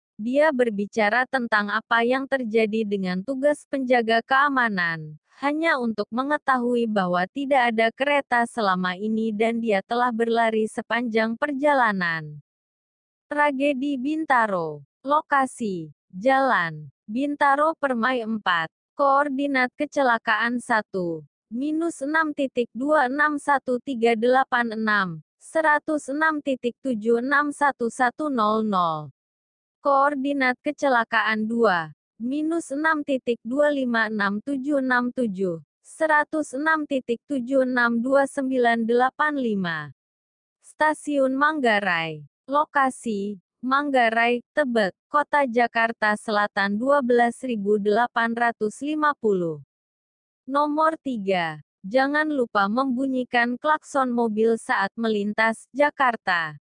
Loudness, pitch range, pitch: -23 LUFS, 215-280 Hz, 245 Hz